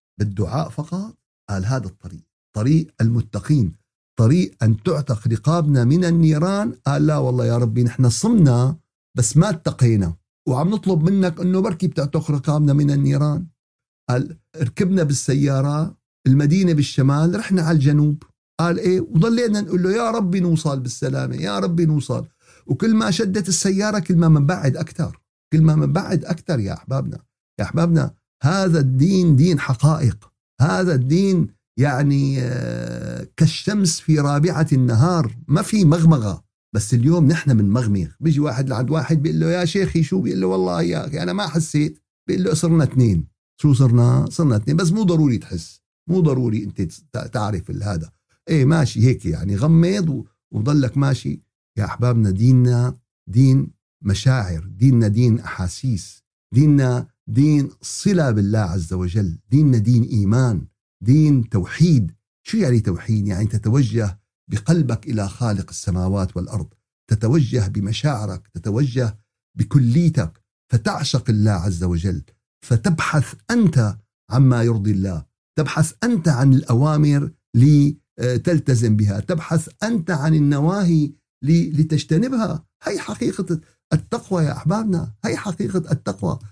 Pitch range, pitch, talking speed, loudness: 115-165 Hz, 140 Hz, 130 wpm, -19 LUFS